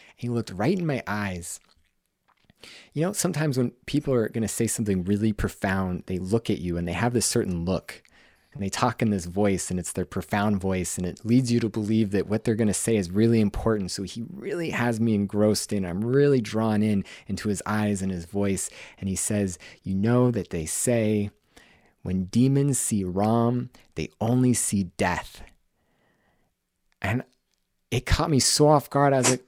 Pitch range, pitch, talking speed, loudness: 95-120 Hz, 105 Hz, 195 wpm, -25 LUFS